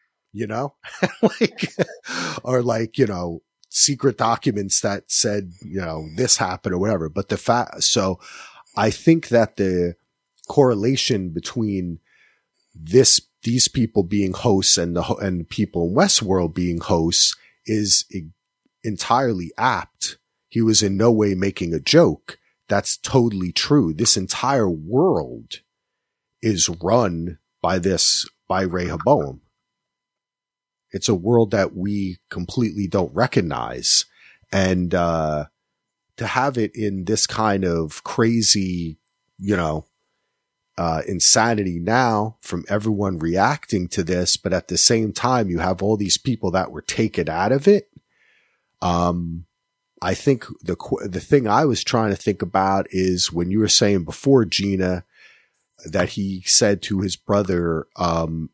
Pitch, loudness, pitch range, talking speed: 100 Hz, -20 LUFS, 90-115 Hz, 140 wpm